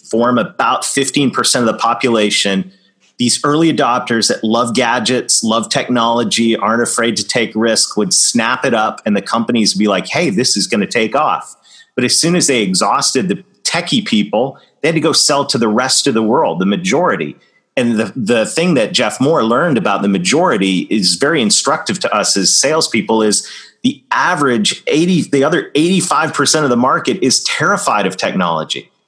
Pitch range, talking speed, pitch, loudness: 110-145 Hz, 190 wpm, 120 Hz, -13 LUFS